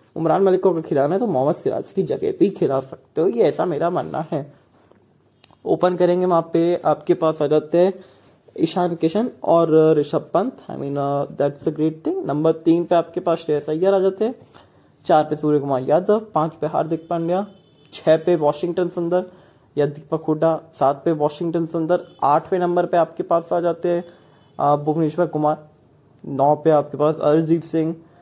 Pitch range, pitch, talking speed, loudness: 150-175 Hz, 165 Hz, 175 wpm, -20 LUFS